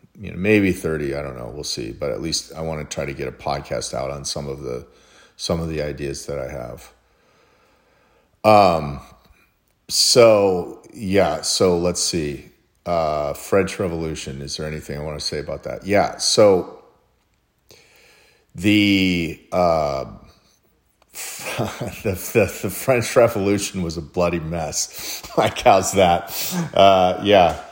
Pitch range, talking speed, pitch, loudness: 70-90 Hz, 145 wpm, 80 Hz, -20 LUFS